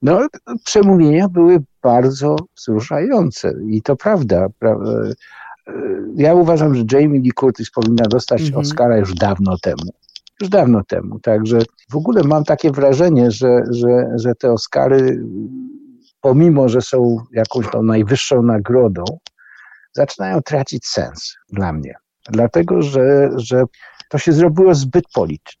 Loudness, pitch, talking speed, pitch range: -15 LUFS, 130 Hz, 125 wpm, 115-160 Hz